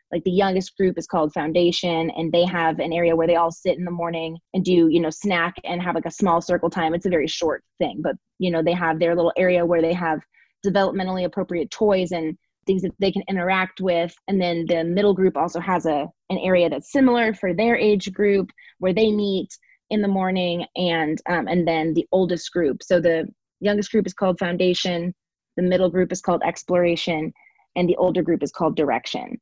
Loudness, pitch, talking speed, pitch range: -22 LUFS, 180 Hz, 215 wpm, 170-190 Hz